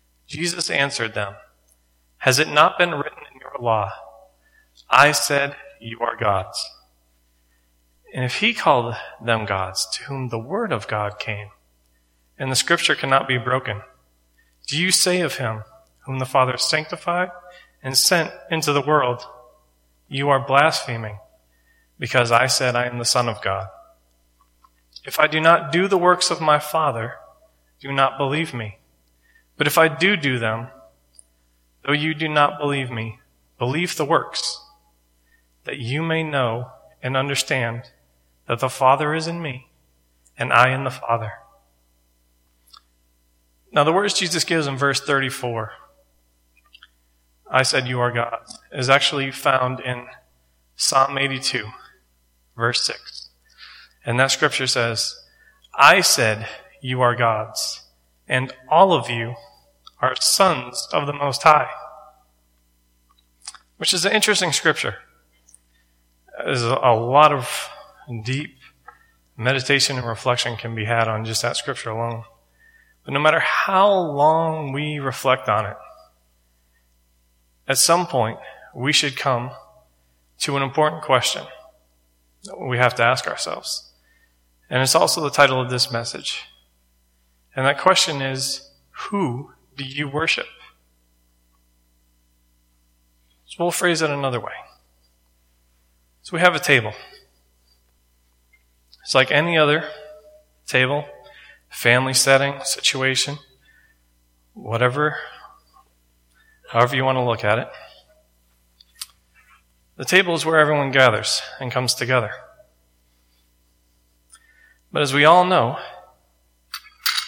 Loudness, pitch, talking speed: -19 LUFS, 120 Hz, 130 wpm